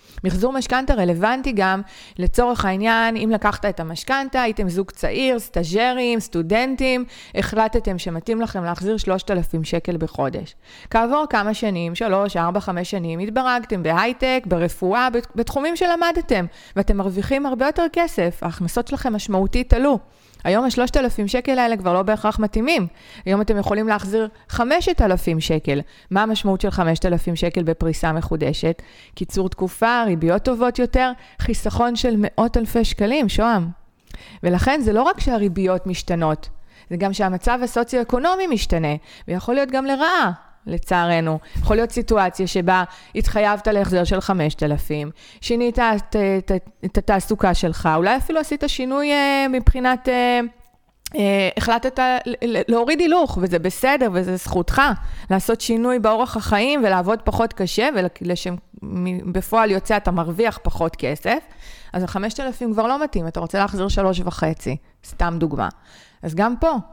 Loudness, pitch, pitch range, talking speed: -20 LUFS, 210 Hz, 180-245 Hz, 130 wpm